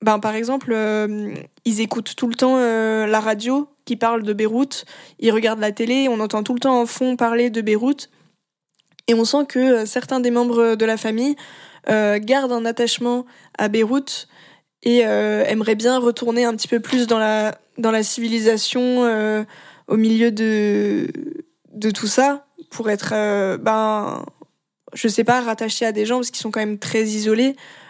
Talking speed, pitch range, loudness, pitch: 185 wpm, 215-250 Hz, -19 LUFS, 230 Hz